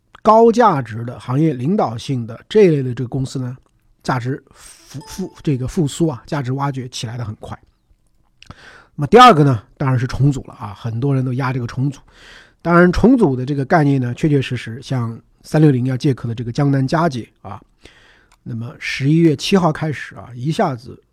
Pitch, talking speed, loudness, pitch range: 135 Hz, 285 characters per minute, -16 LUFS, 125-155 Hz